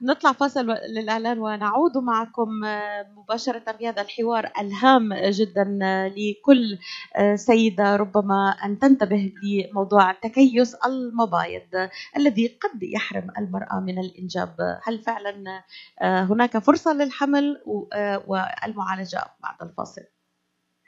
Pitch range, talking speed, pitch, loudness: 195-235 Hz, 90 wpm, 210 Hz, -22 LUFS